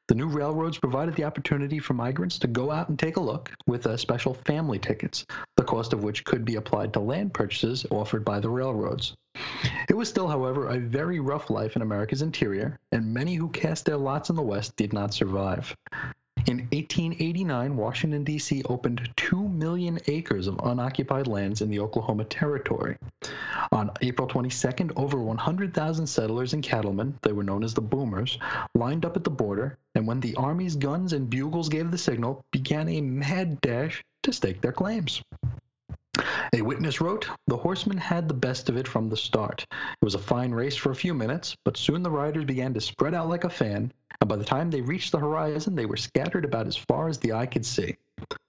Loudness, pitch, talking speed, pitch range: -28 LUFS, 140 Hz, 200 wpm, 120-160 Hz